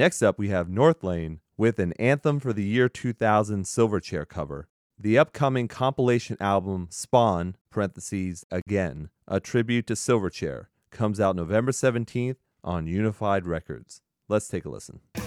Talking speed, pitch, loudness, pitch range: 140 wpm, 105 Hz, -26 LUFS, 90-120 Hz